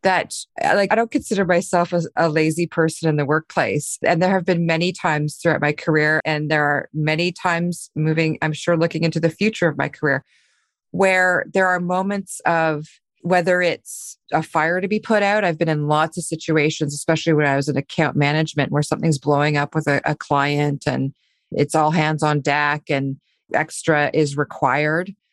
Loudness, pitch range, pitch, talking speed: -20 LUFS, 150-175 Hz, 160 Hz, 190 wpm